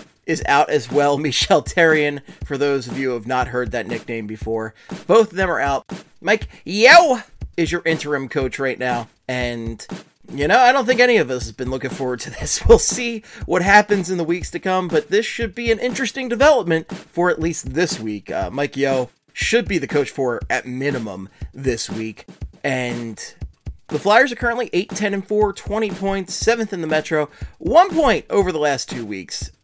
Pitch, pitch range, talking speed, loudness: 155 Hz, 130-205 Hz, 200 wpm, -19 LUFS